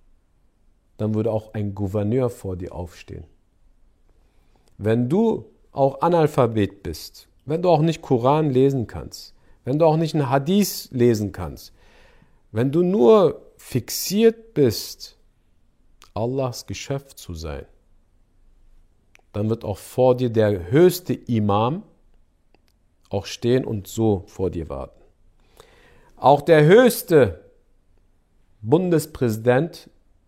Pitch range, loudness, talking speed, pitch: 90-140 Hz, -20 LUFS, 110 wpm, 110 Hz